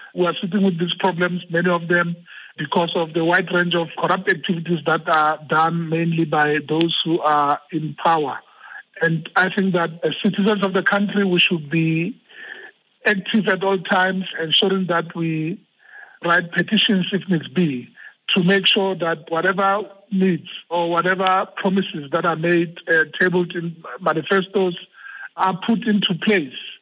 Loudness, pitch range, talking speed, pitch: -19 LUFS, 165-195 Hz, 160 wpm, 180 Hz